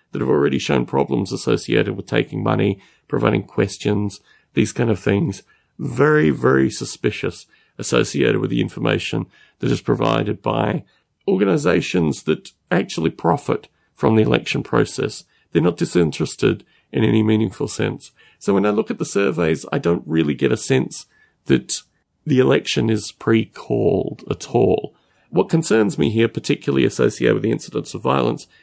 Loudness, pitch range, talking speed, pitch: -20 LUFS, 75-110 Hz, 150 wpm, 100 Hz